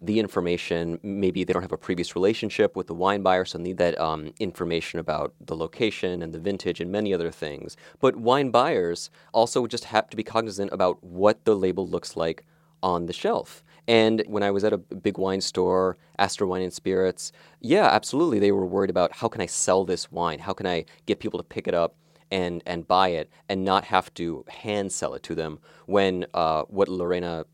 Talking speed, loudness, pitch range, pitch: 210 wpm, -25 LUFS, 85-100 Hz, 95 Hz